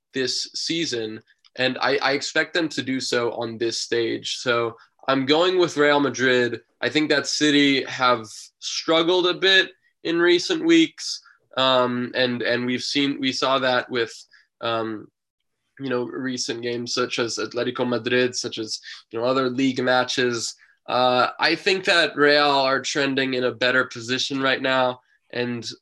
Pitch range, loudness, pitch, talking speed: 120-145 Hz, -22 LUFS, 130 Hz, 160 wpm